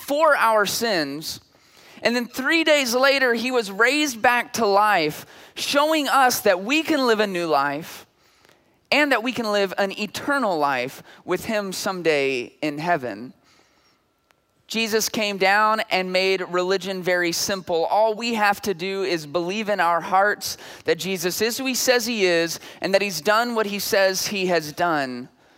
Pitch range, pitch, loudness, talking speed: 180-235 Hz, 200 Hz, -21 LUFS, 170 wpm